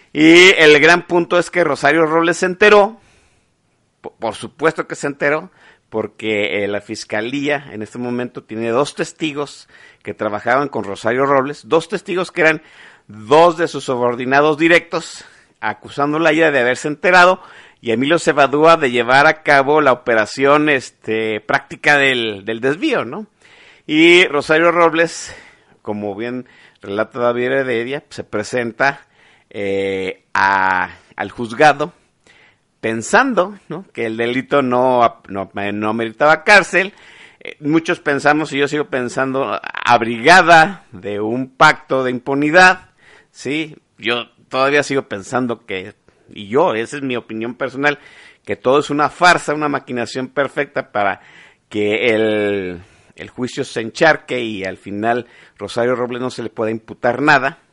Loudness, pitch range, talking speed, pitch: -15 LUFS, 115-160 Hz, 140 wpm, 135 Hz